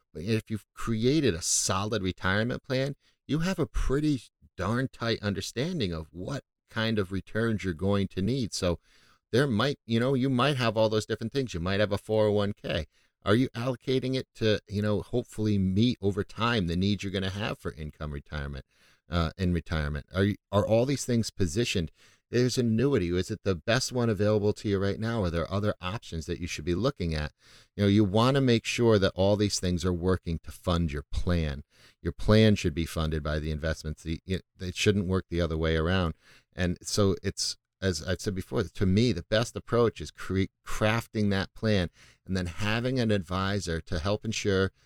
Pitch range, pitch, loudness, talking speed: 90-115 Hz, 100 Hz, -29 LUFS, 200 wpm